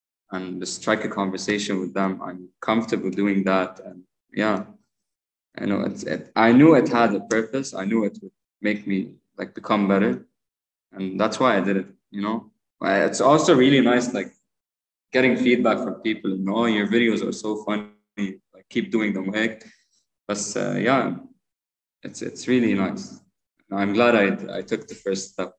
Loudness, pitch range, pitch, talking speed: -22 LUFS, 95-115 Hz, 105 Hz, 190 wpm